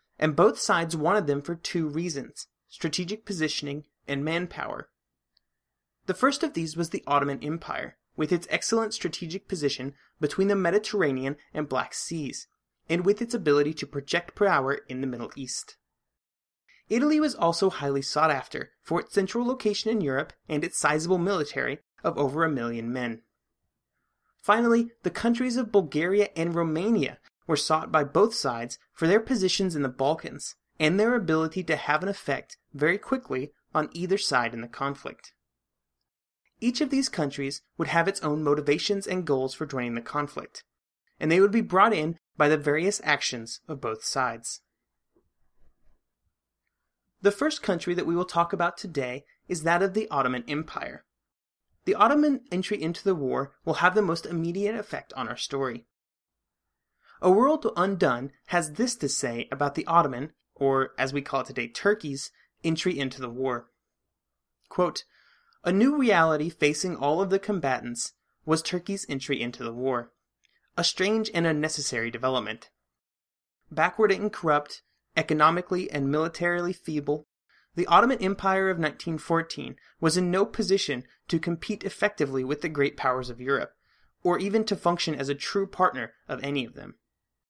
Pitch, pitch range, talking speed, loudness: 160 Hz, 140-195 Hz, 160 wpm, -27 LUFS